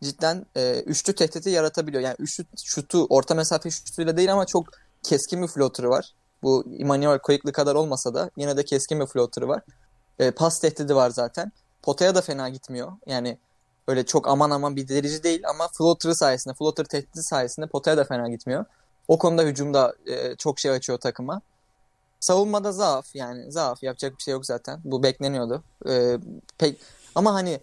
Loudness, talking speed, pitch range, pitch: -24 LUFS, 175 wpm, 130-165 Hz, 145 Hz